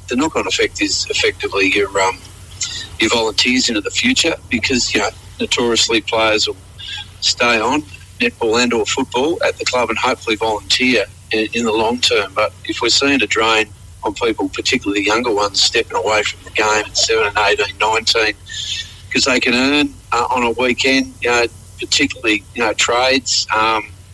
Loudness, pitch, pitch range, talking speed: -15 LUFS, 110 Hz, 100-135 Hz, 180 wpm